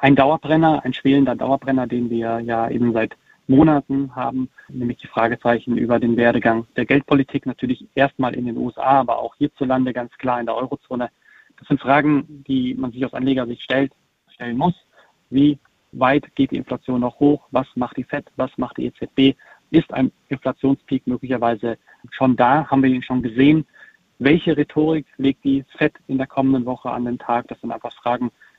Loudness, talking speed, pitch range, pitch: -20 LUFS, 180 wpm, 120-140 Hz, 130 Hz